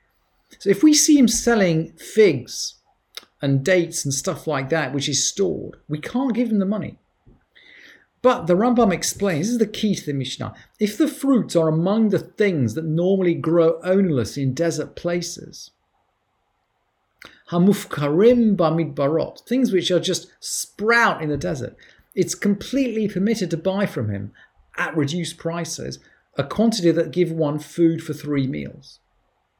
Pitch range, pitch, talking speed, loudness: 155-205 Hz, 175 Hz, 150 wpm, -21 LUFS